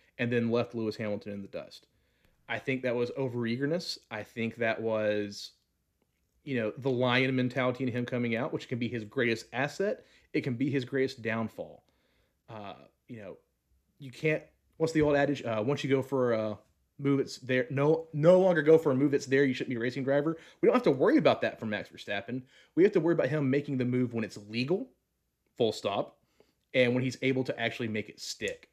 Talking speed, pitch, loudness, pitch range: 215 wpm, 125 Hz, -30 LUFS, 115-140 Hz